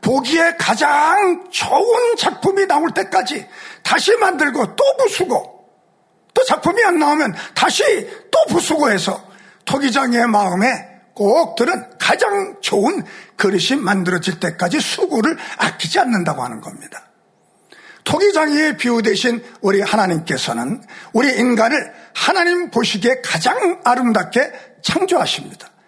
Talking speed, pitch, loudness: 275 characters per minute, 275 Hz, -16 LUFS